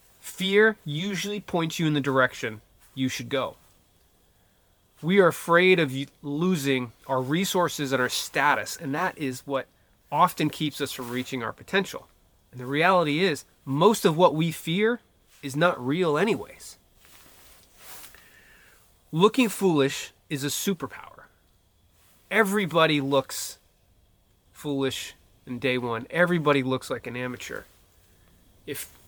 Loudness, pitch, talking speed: -25 LUFS, 135 Hz, 125 wpm